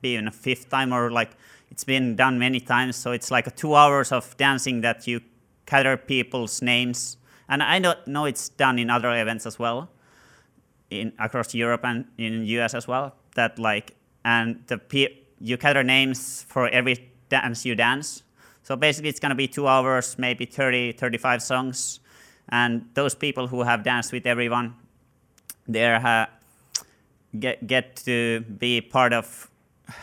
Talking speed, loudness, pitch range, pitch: 170 wpm, -23 LUFS, 120-135 Hz, 125 Hz